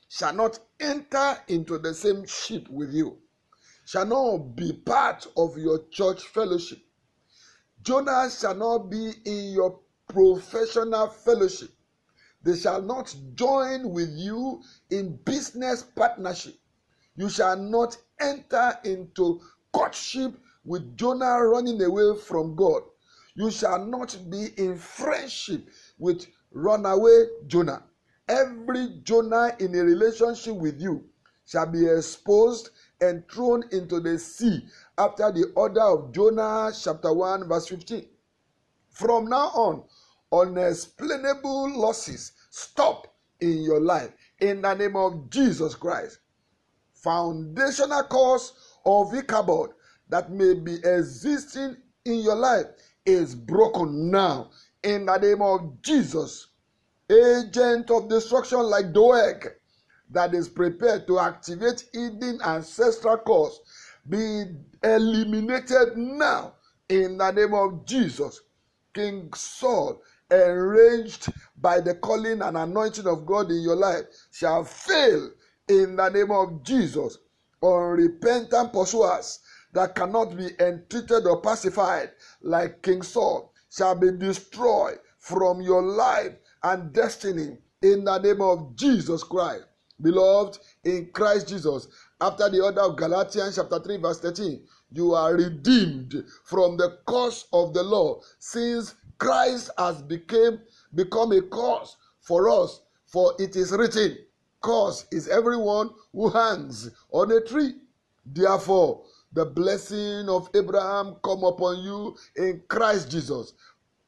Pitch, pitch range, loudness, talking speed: 205 Hz, 180-240 Hz, -24 LUFS, 120 wpm